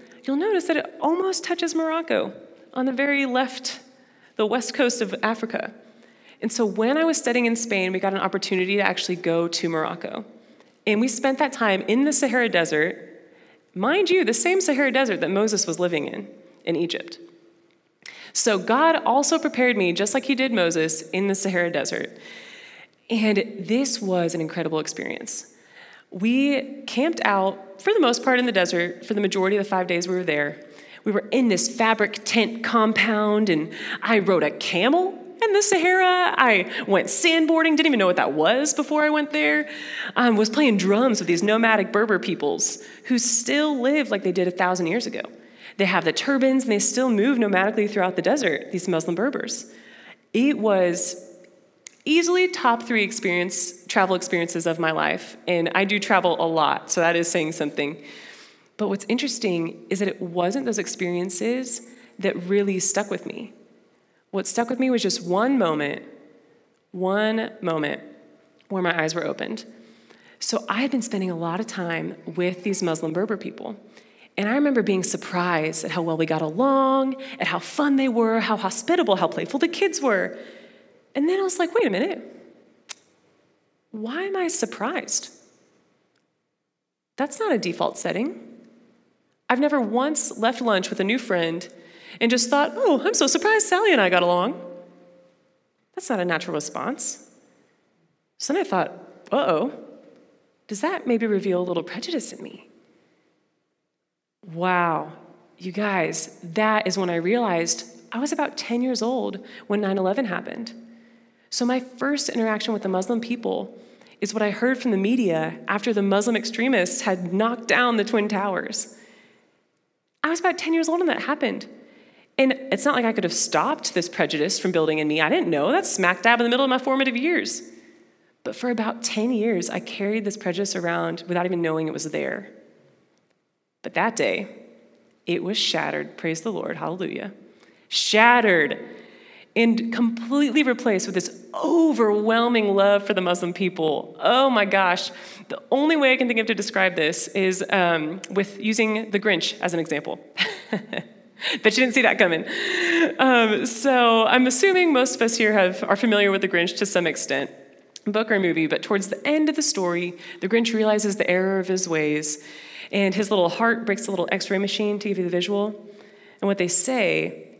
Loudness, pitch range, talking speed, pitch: -22 LUFS, 180-260 Hz, 180 wpm, 215 Hz